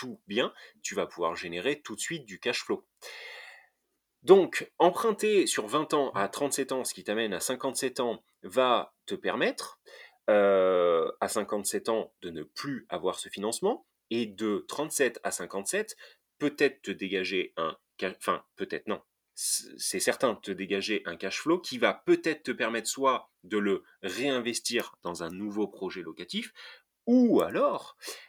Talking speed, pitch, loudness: 155 wpm, 130 Hz, -30 LUFS